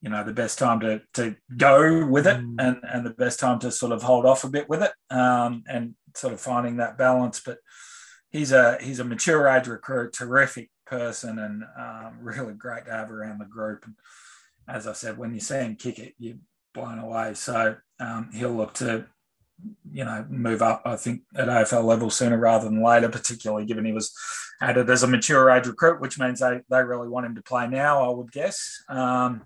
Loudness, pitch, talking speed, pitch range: -23 LUFS, 125 Hz, 215 wpm, 115-130 Hz